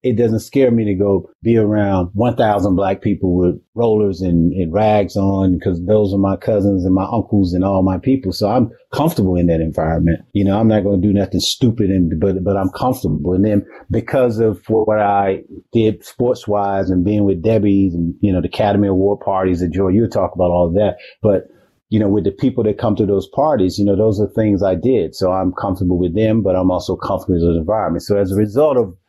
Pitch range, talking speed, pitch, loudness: 95-110 Hz, 230 wpm, 100 Hz, -16 LUFS